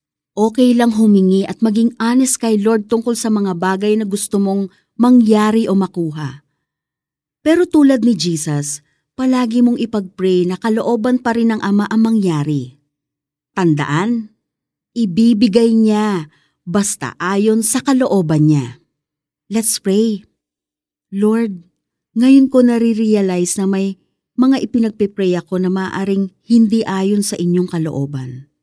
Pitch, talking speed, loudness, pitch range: 200 Hz, 125 wpm, -15 LUFS, 165-230 Hz